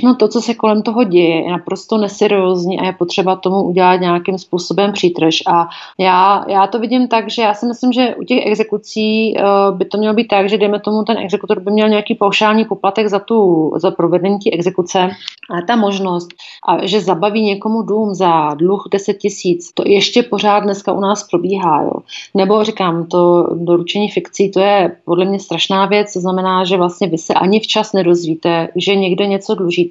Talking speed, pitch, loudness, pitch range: 195 wpm, 195 Hz, -14 LUFS, 180-210 Hz